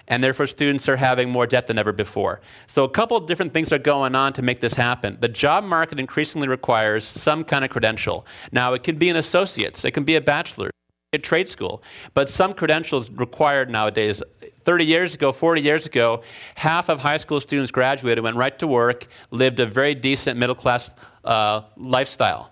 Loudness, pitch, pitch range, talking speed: -21 LUFS, 135 Hz, 120-150 Hz, 200 wpm